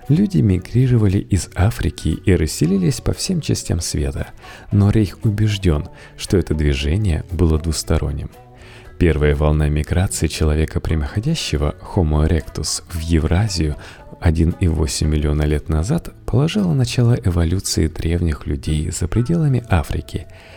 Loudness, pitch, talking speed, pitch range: -19 LUFS, 90 Hz, 115 wpm, 80-110 Hz